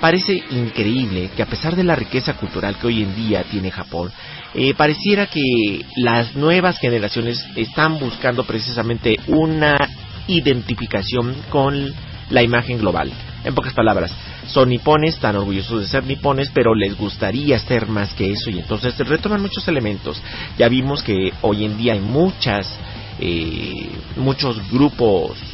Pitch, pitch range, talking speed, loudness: 120 Hz, 105-140 Hz, 150 wpm, -18 LUFS